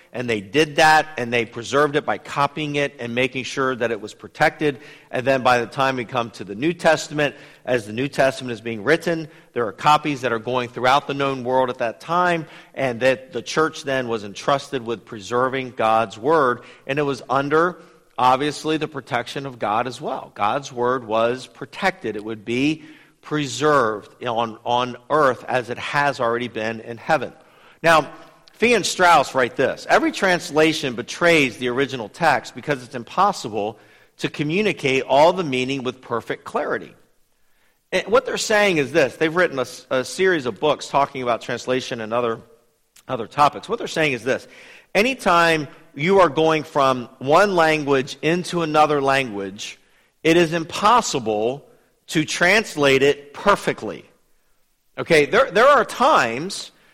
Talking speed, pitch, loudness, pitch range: 165 wpm, 140 Hz, -20 LUFS, 125-155 Hz